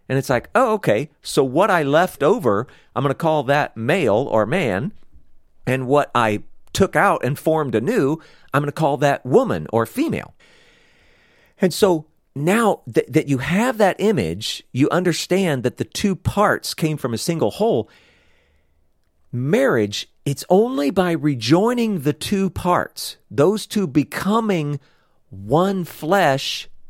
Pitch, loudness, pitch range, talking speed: 150 Hz, -19 LUFS, 120-185 Hz, 145 wpm